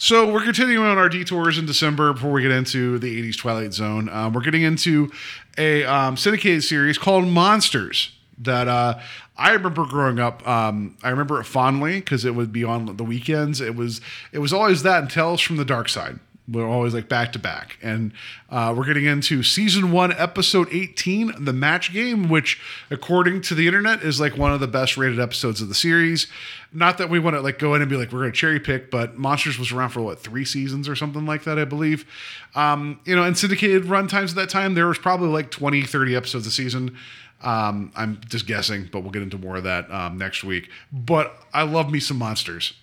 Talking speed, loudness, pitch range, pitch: 225 wpm, -20 LUFS, 120-170 Hz, 145 Hz